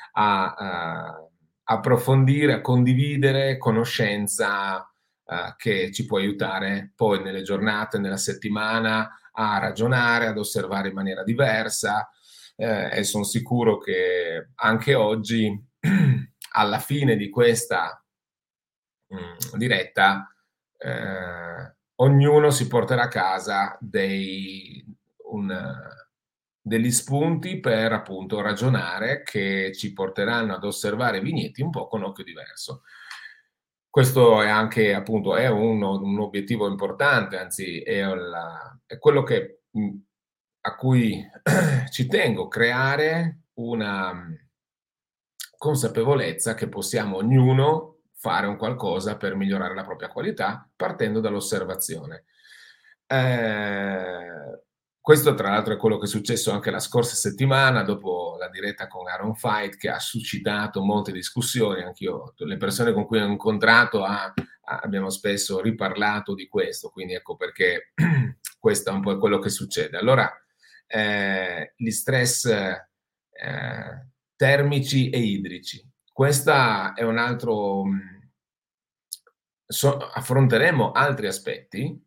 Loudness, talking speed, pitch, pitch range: -23 LUFS, 115 wpm, 115 Hz, 100-135 Hz